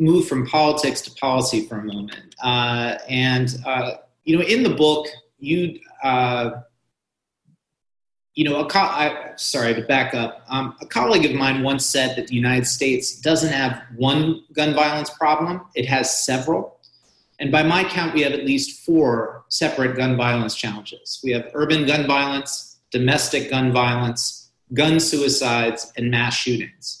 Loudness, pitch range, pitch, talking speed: -20 LUFS, 125-150 Hz, 135 Hz, 160 wpm